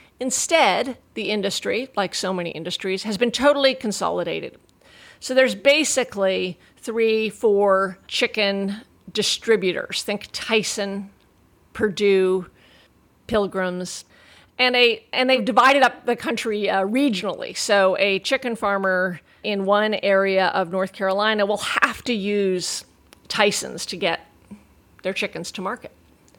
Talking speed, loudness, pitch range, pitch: 120 wpm, -21 LUFS, 190-230 Hz, 205 Hz